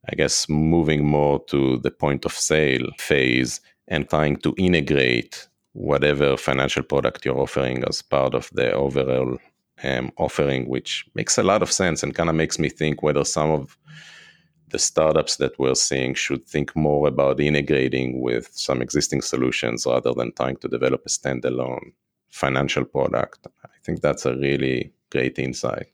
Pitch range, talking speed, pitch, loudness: 65-75 Hz, 165 wpm, 70 Hz, -22 LUFS